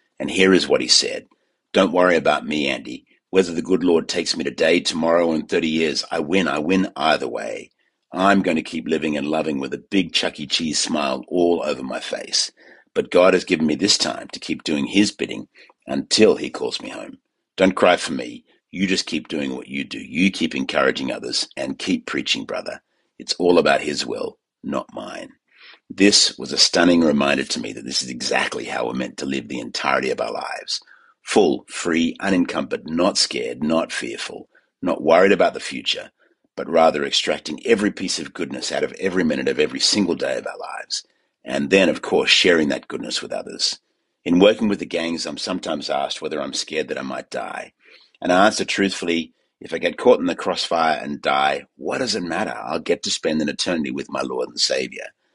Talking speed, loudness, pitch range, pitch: 210 wpm, -20 LUFS, 75-95 Hz, 85 Hz